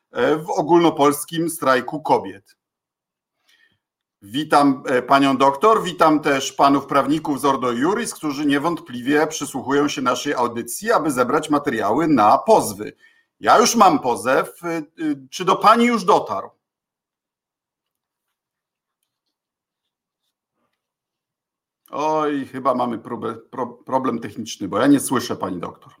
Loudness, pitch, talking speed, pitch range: -19 LUFS, 150 Hz, 105 wpm, 140-165 Hz